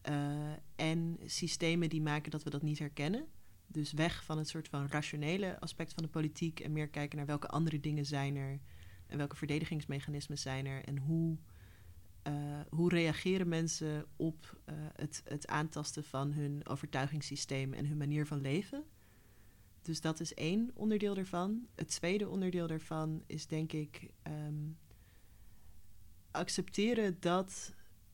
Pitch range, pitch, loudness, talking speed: 140-165 Hz, 150 Hz, -38 LUFS, 150 wpm